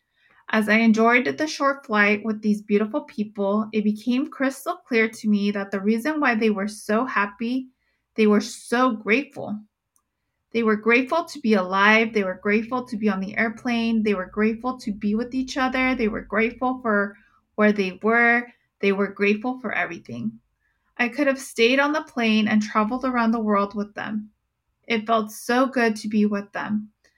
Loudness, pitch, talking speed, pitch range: -22 LUFS, 220 Hz, 185 wpm, 210-245 Hz